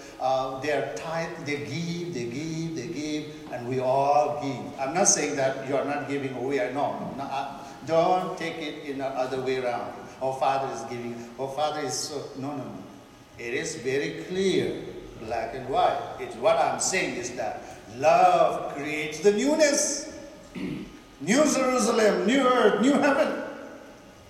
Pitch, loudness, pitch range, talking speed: 150 Hz, -26 LUFS, 135-205 Hz, 165 wpm